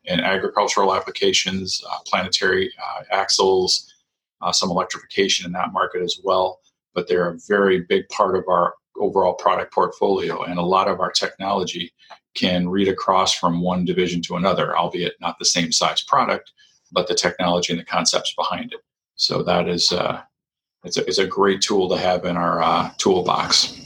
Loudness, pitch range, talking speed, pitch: -20 LUFS, 85-95 Hz, 175 wpm, 90 Hz